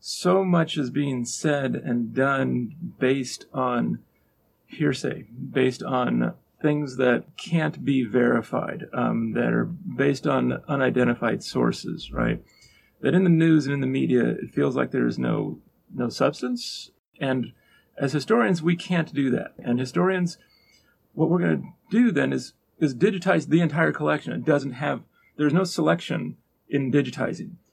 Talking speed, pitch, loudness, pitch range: 150 wpm, 140 Hz, -24 LUFS, 125-170 Hz